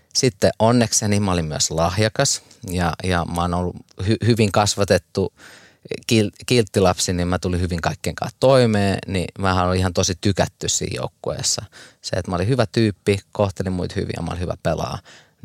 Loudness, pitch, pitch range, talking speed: -20 LUFS, 95 Hz, 90-110 Hz, 175 wpm